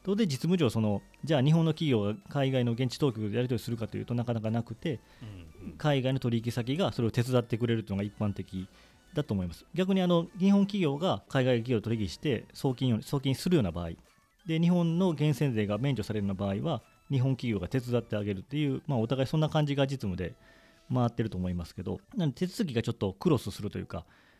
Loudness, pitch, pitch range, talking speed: -30 LUFS, 120 Hz, 105-150 Hz, 440 characters per minute